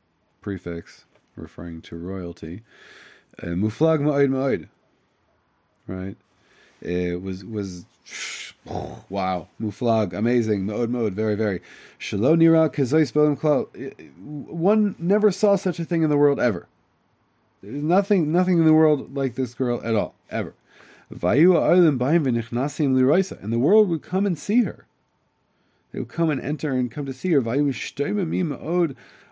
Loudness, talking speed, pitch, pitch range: -22 LUFS, 125 wpm, 130 Hz, 105-160 Hz